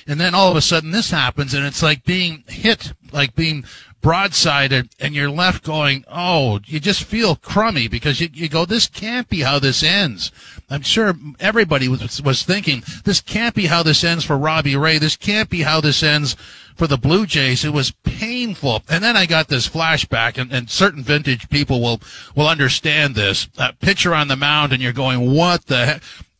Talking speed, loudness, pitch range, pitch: 200 wpm, -16 LUFS, 135-170 Hz, 150 Hz